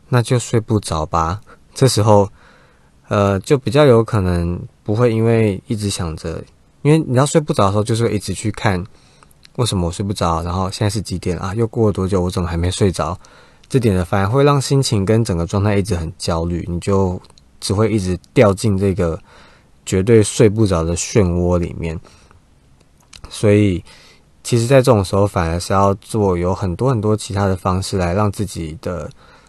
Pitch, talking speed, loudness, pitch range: 100 Hz, 275 characters per minute, -17 LUFS, 90-110 Hz